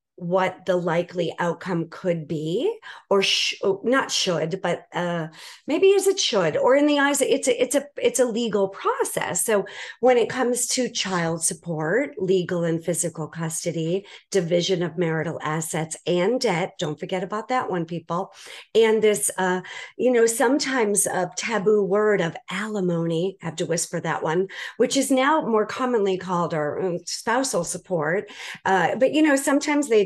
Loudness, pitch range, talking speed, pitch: -23 LUFS, 175-245 Hz, 170 wpm, 190 Hz